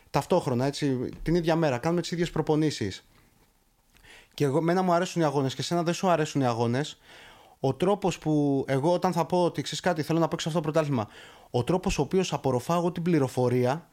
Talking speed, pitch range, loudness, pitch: 200 wpm, 135-175 Hz, -27 LUFS, 155 Hz